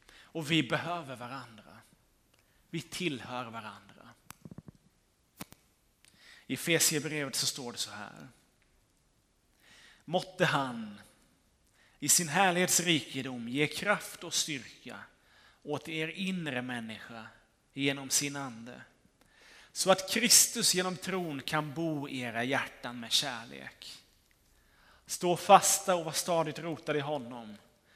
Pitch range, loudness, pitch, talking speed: 125-175 Hz, -30 LUFS, 150 Hz, 110 wpm